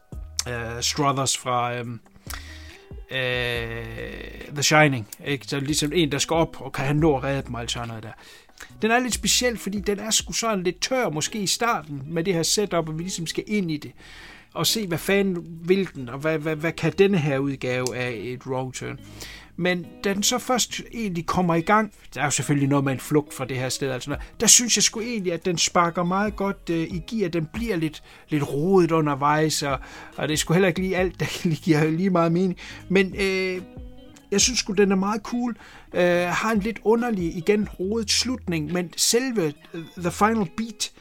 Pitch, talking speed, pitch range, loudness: 170 Hz, 205 wpm, 140-200 Hz, -23 LUFS